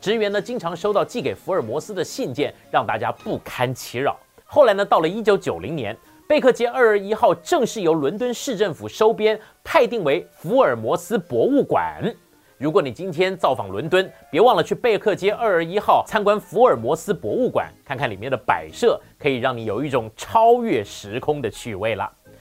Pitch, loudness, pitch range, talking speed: 210 Hz, -21 LUFS, 170-230 Hz, 295 characters per minute